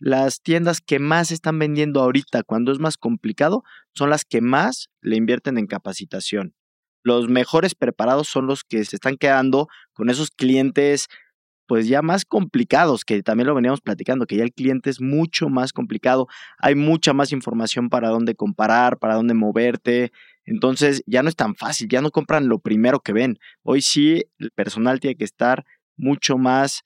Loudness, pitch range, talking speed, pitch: -20 LUFS, 115-145 Hz, 180 wpm, 130 Hz